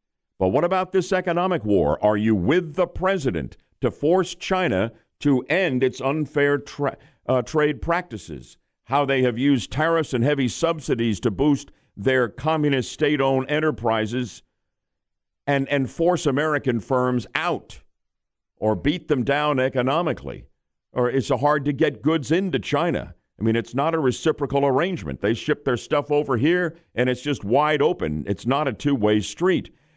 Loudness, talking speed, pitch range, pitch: -22 LUFS, 155 wpm, 125-155 Hz, 140 Hz